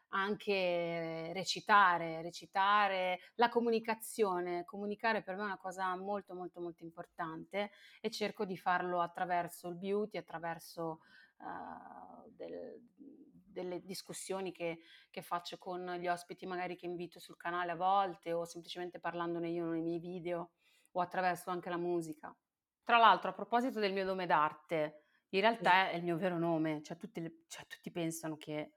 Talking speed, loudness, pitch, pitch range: 150 wpm, -36 LUFS, 180 Hz, 170-195 Hz